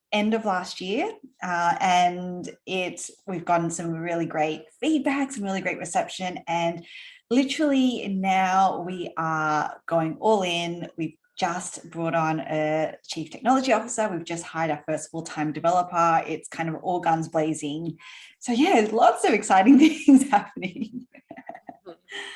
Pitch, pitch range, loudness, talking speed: 180 Hz, 165-230 Hz, -24 LUFS, 145 wpm